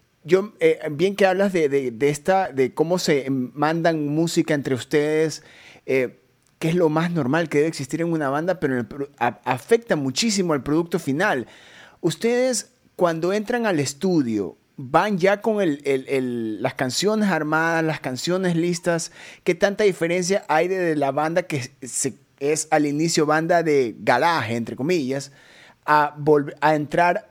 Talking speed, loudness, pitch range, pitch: 165 wpm, -22 LUFS, 140-180 Hz, 155 Hz